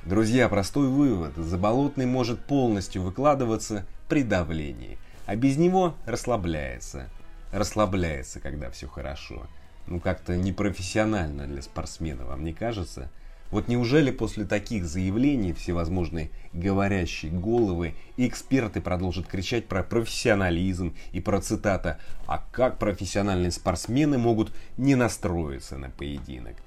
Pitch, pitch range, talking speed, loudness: 95 Hz, 80-110 Hz, 110 wpm, -27 LUFS